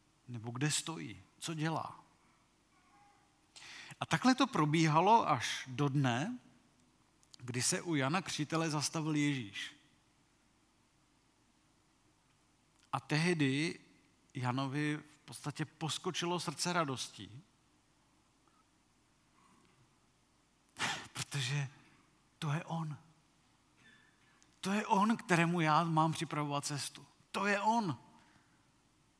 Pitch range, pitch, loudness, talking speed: 140-165 Hz, 150 Hz, -35 LUFS, 85 wpm